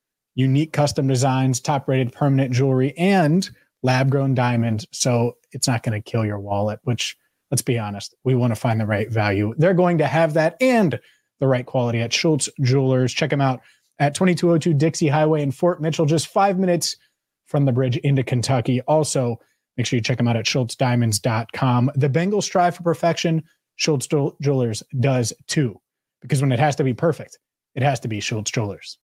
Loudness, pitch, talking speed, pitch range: -20 LUFS, 135 Hz, 190 wpm, 125-155 Hz